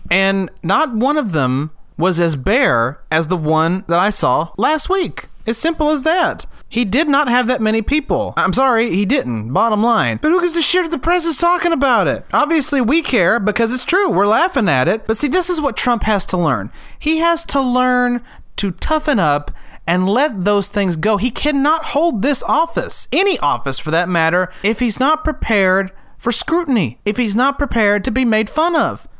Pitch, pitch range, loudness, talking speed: 240 Hz, 190-305 Hz, -16 LUFS, 210 wpm